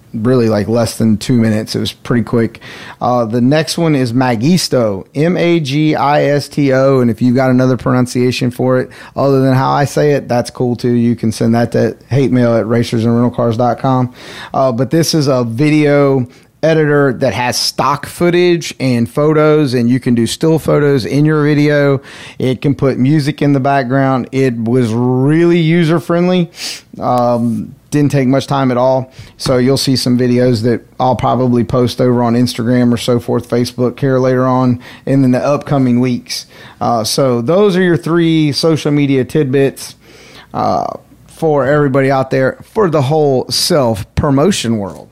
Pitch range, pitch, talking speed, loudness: 120-145 Hz, 130 Hz, 180 wpm, -13 LUFS